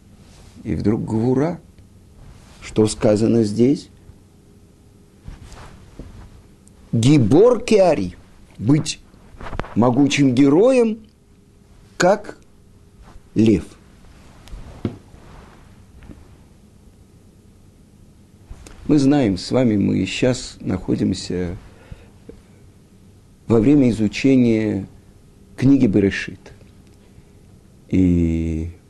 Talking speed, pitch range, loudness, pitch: 55 wpm, 95-115 Hz, -18 LUFS, 100 Hz